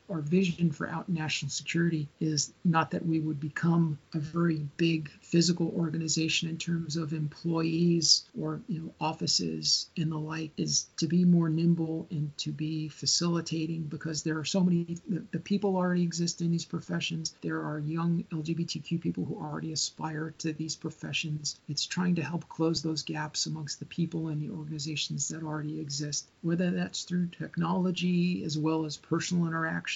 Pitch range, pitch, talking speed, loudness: 155-170 Hz, 160 Hz, 170 wpm, -30 LUFS